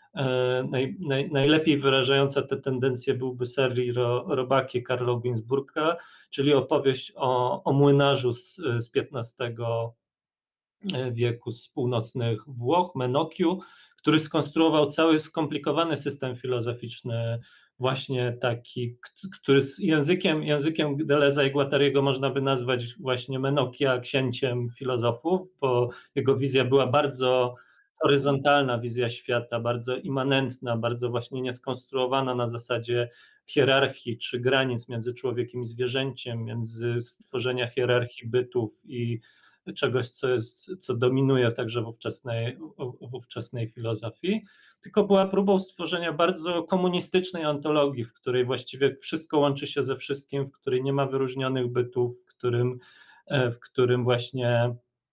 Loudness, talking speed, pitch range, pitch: -26 LUFS, 120 wpm, 120-140 Hz, 130 Hz